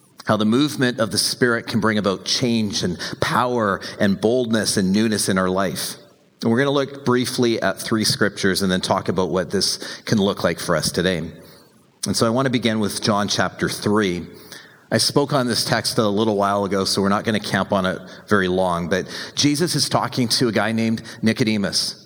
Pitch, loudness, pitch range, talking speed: 110 Hz, -20 LUFS, 100-125 Hz, 210 wpm